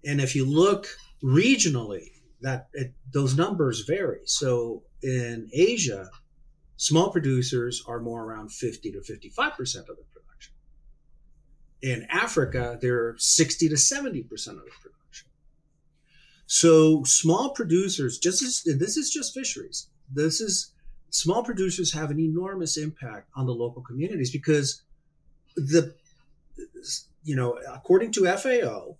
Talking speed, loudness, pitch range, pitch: 125 wpm, -24 LUFS, 130-175 Hz, 150 Hz